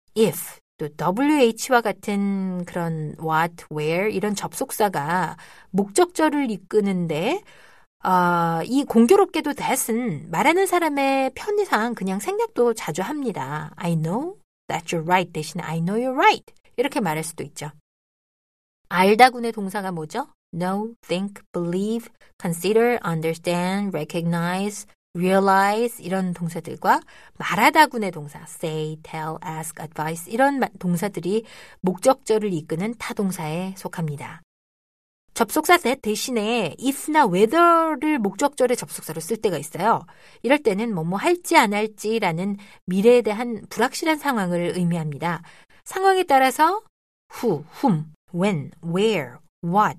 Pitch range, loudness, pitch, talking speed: 170-245 Hz, -22 LUFS, 200 Hz, 370 characters per minute